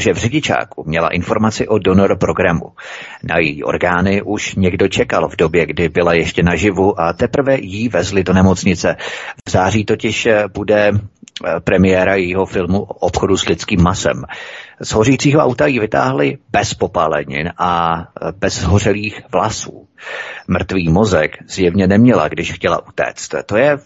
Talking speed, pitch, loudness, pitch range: 145 wpm, 95 Hz, -15 LUFS, 90-110 Hz